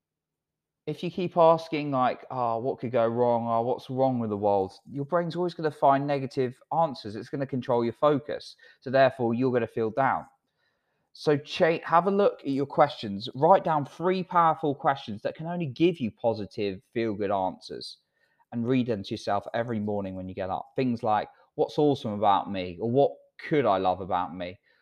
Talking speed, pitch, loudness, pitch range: 200 wpm, 130 Hz, -27 LUFS, 115-150 Hz